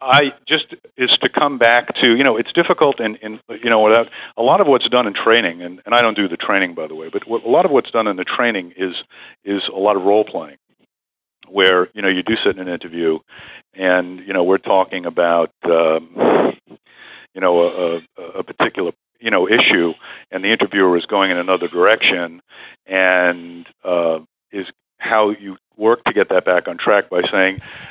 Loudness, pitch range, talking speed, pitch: -16 LUFS, 85-105 Hz, 205 wpm, 95 Hz